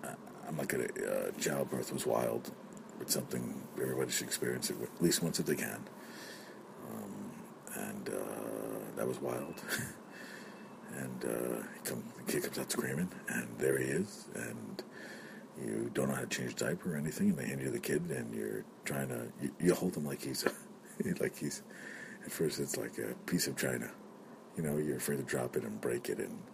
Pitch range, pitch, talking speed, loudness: 65-75 Hz, 70 Hz, 190 wpm, -37 LUFS